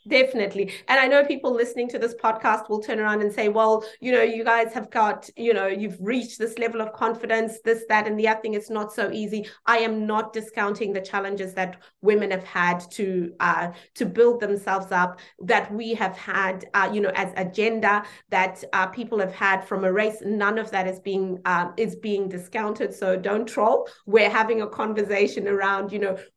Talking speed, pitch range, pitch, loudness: 210 wpm, 195-225 Hz, 210 Hz, -24 LUFS